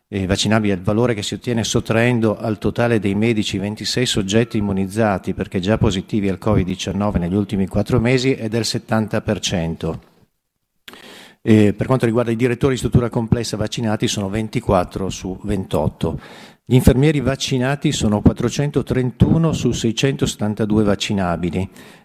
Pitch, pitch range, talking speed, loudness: 110 Hz, 100-120 Hz, 135 wpm, -19 LUFS